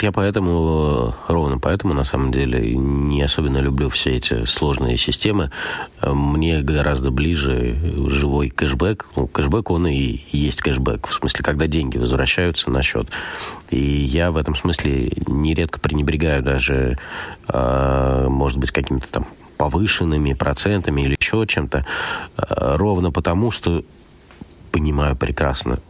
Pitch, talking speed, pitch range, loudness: 70 Hz, 125 wpm, 65-80 Hz, -19 LUFS